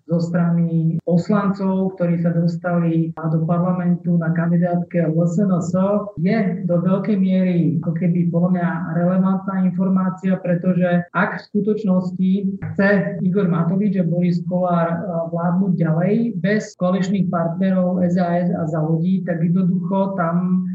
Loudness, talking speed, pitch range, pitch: -19 LUFS, 130 wpm, 170-190 Hz, 180 Hz